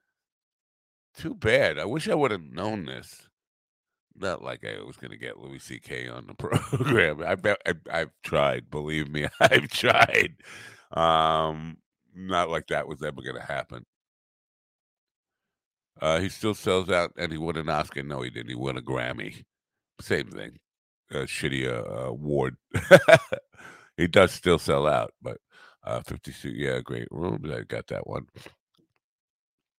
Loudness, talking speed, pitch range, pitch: -25 LUFS, 150 wpm, 65-80 Hz, 75 Hz